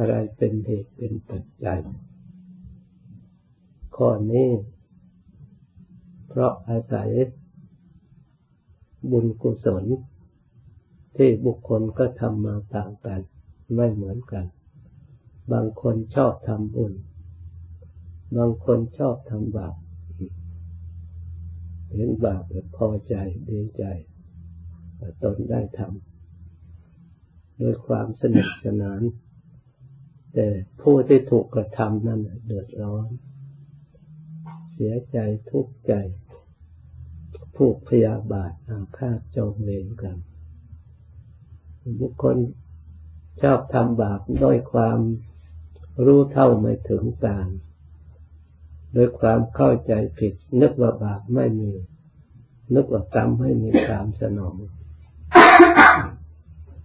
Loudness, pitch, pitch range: -21 LUFS, 105 Hz, 85-120 Hz